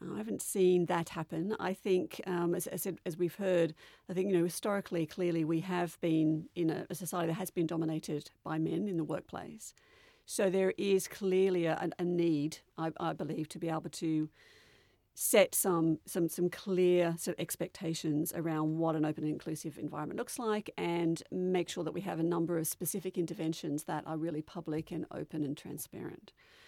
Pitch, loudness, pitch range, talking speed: 170 Hz, -34 LUFS, 160-185 Hz, 190 wpm